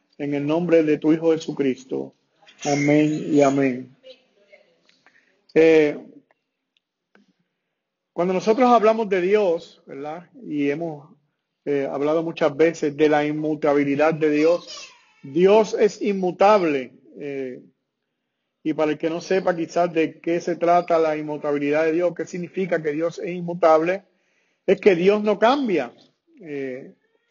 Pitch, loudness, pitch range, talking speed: 160 Hz, -21 LUFS, 150-185 Hz, 130 wpm